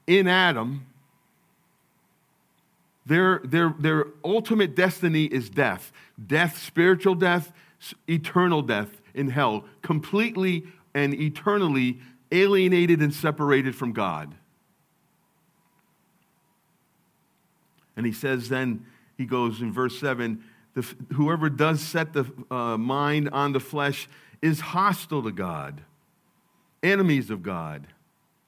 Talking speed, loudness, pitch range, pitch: 105 wpm, -24 LUFS, 130-180 Hz, 155 Hz